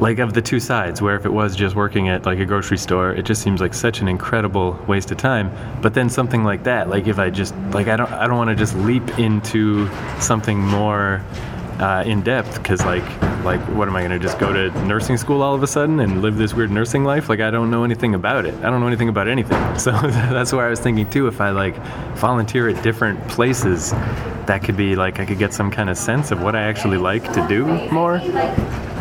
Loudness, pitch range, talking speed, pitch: -19 LUFS, 100-120 Hz, 245 wpm, 110 Hz